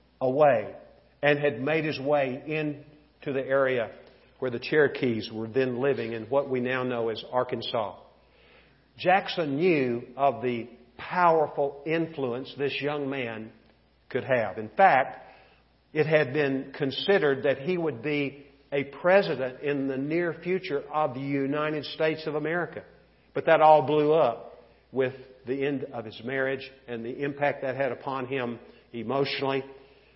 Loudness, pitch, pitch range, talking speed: -27 LUFS, 140 Hz, 130-150 Hz, 145 wpm